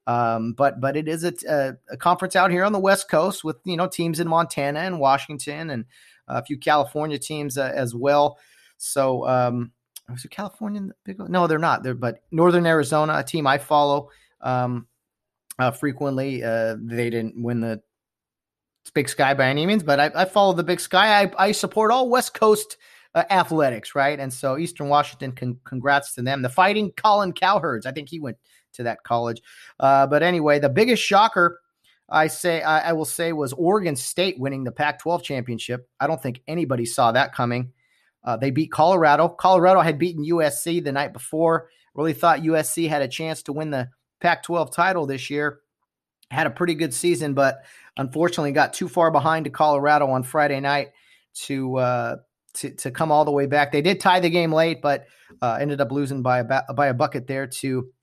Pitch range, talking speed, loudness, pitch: 135-170 Hz, 195 wpm, -21 LUFS, 150 Hz